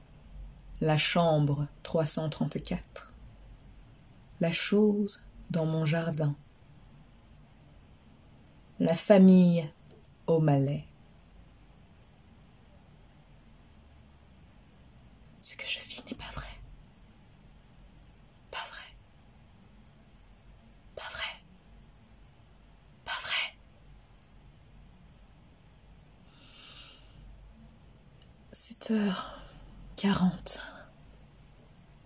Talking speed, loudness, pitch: 50 wpm, -27 LUFS, 155 Hz